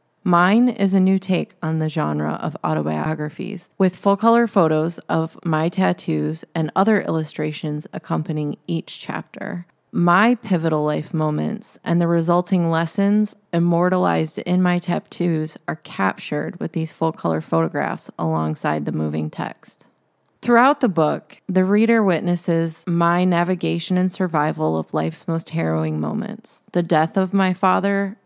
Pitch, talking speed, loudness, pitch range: 170 Hz, 140 wpm, -20 LUFS, 155-190 Hz